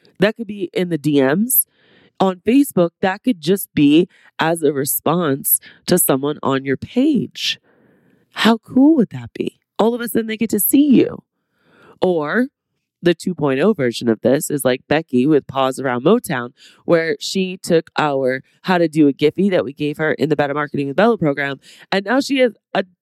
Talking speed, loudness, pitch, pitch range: 190 wpm, -17 LUFS, 170 Hz, 145-215 Hz